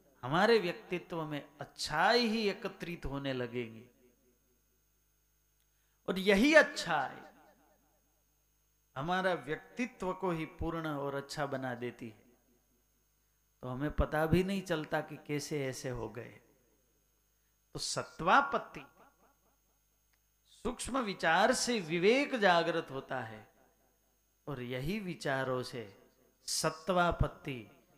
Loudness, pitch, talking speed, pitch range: -33 LUFS, 150 Hz, 100 wpm, 130-185 Hz